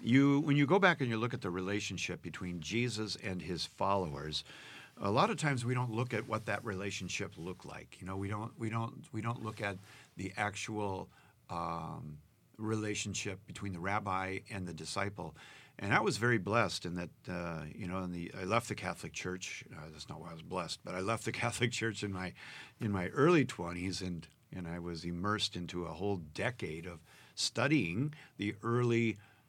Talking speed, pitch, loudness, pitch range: 200 wpm, 100 Hz, -36 LUFS, 90-115 Hz